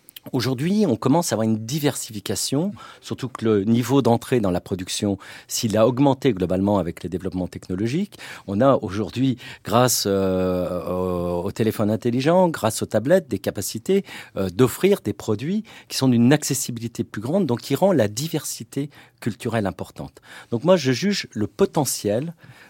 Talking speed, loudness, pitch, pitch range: 155 wpm, -22 LUFS, 120 Hz, 100-140 Hz